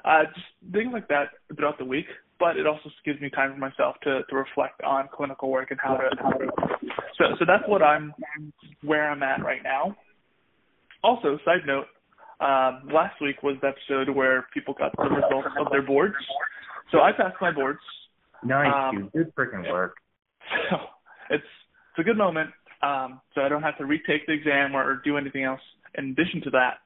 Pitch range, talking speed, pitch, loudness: 135-155 Hz, 195 wpm, 140 Hz, -25 LUFS